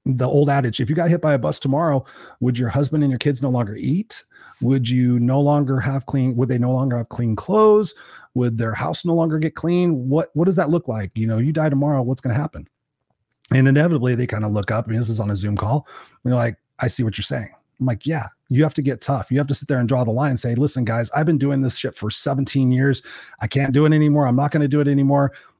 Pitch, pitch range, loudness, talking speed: 135 Hz, 125-145 Hz, -20 LUFS, 280 wpm